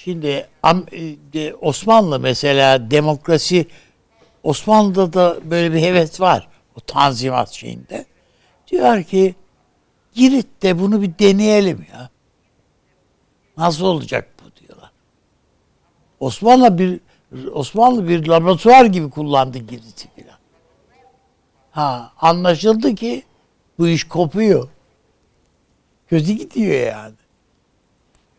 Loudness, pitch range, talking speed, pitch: -15 LUFS, 145-200 Hz, 90 wpm, 170 Hz